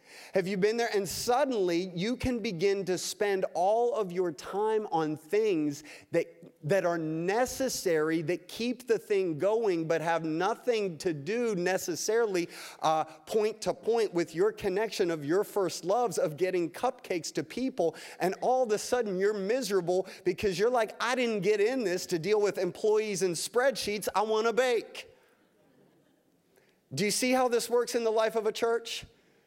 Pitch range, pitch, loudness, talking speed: 180-240 Hz, 210 Hz, -30 LUFS, 175 wpm